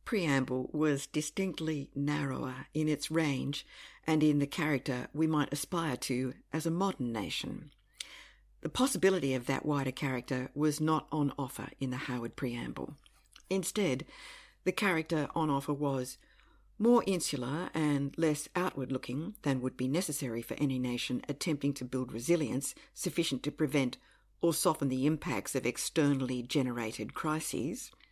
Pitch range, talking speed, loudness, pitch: 130-160 Hz, 145 wpm, -33 LUFS, 145 Hz